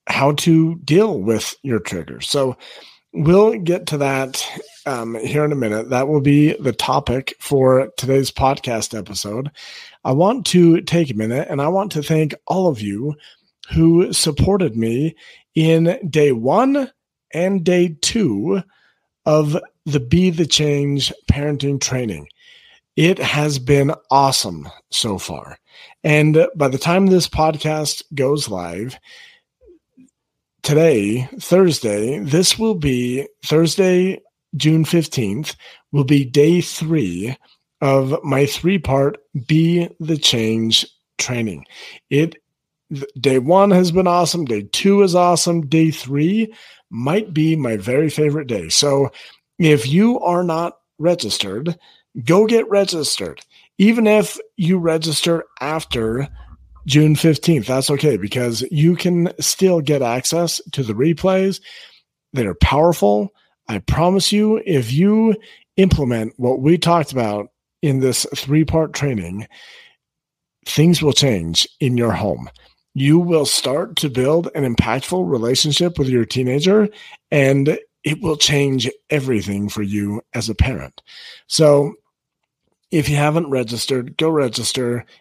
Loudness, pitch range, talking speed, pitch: -17 LUFS, 130-175 Hz, 130 wpm, 150 Hz